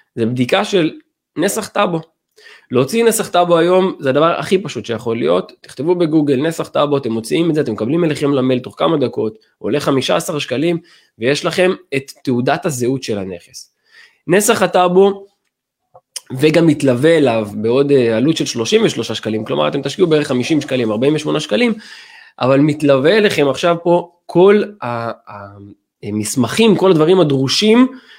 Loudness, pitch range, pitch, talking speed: -15 LUFS, 130-185 Hz, 155 Hz, 145 wpm